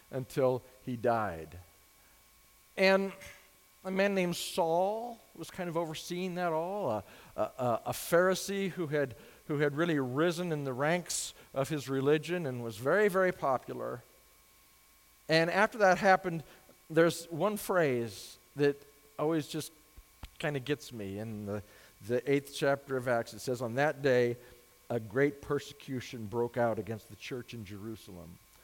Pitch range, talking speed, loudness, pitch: 120-170 Hz, 150 wpm, -32 LUFS, 140 Hz